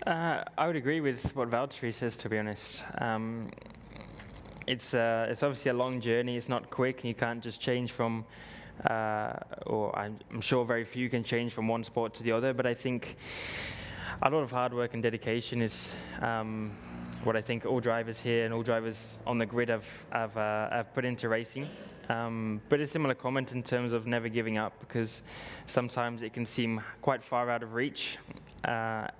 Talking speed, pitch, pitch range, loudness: 195 wpm, 115 Hz, 115-125 Hz, -33 LUFS